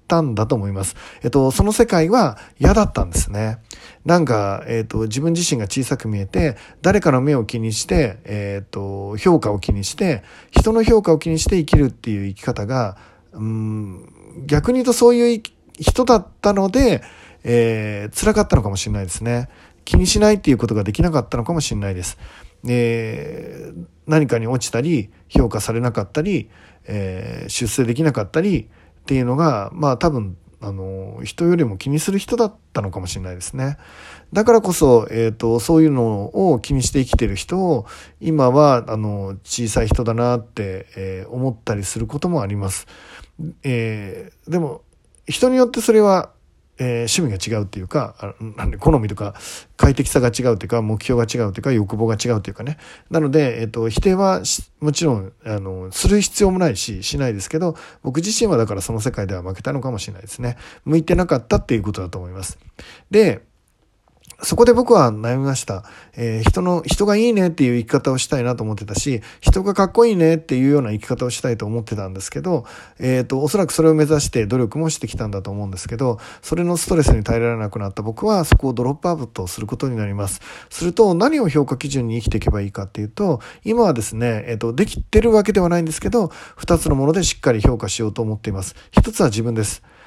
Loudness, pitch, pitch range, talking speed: -19 LUFS, 120 Hz, 105-160 Hz, 400 characters per minute